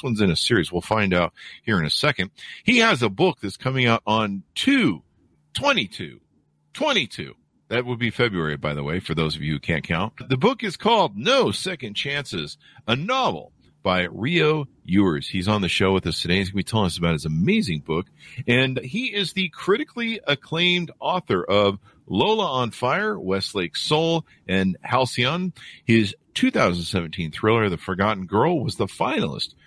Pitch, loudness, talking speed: 115 Hz, -22 LUFS, 175 wpm